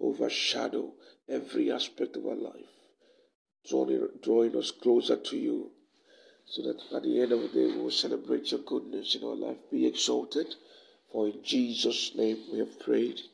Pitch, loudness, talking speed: 310 Hz, -30 LUFS, 160 wpm